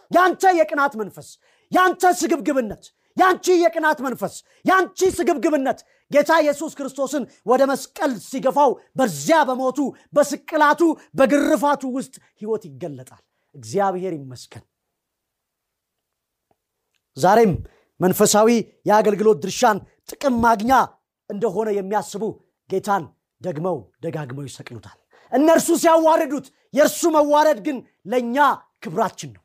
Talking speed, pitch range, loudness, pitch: 90 wpm, 200-305 Hz, -19 LUFS, 260 Hz